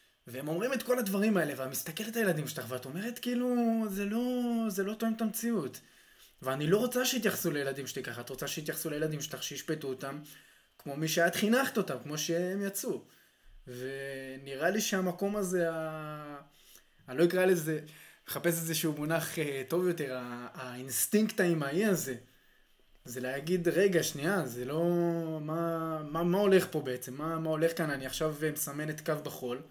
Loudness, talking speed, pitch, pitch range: -32 LUFS, 170 wpm, 160 Hz, 140-190 Hz